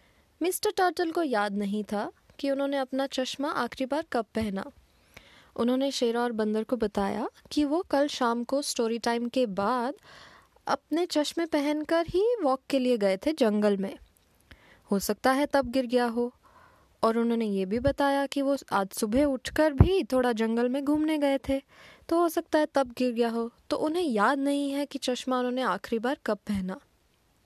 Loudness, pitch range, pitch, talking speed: -28 LUFS, 230-295 Hz, 265 Hz, 185 wpm